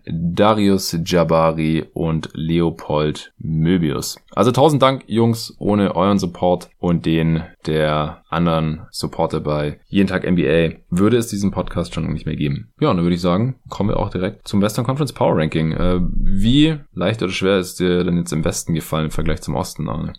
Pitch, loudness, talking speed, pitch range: 90 Hz, -19 LUFS, 180 wpm, 80-100 Hz